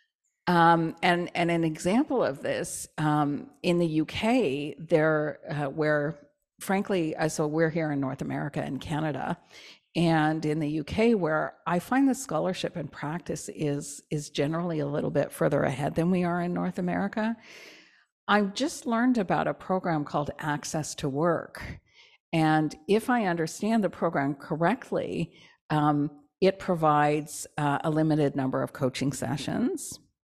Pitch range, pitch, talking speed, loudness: 150-185 Hz, 160 Hz, 150 wpm, -28 LUFS